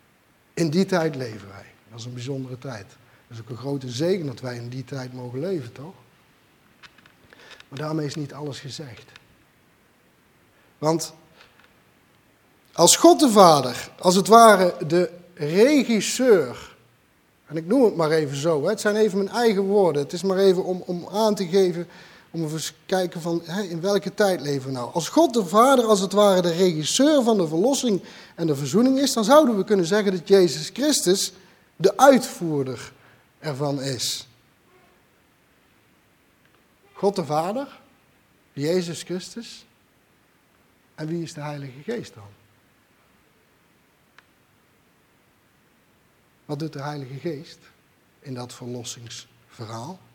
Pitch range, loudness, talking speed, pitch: 140-200 Hz, -21 LUFS, 145 wpm, 170 Hz